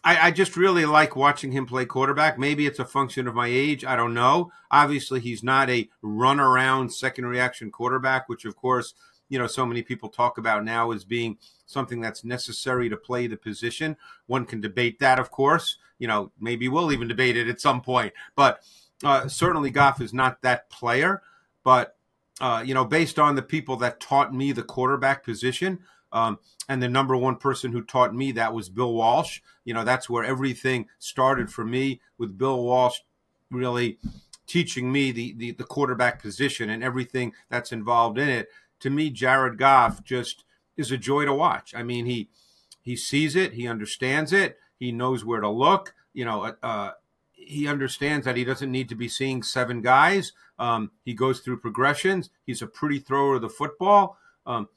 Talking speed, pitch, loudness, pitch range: 190 wpm, 130 Hz, -24 LUFS, 120-140 Hz